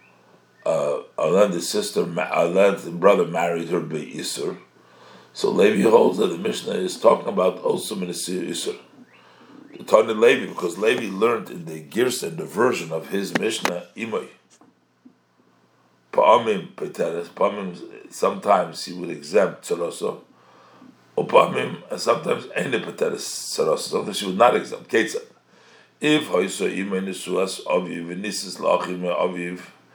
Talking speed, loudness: 130 wpm, -22 LUFS